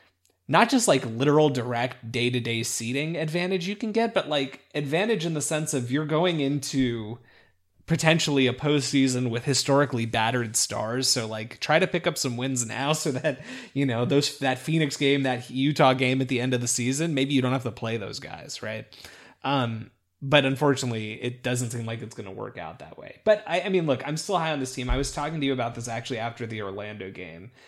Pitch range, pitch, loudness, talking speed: 120-150 Hz, 130 Hz, -25 LUFS, 215 wpm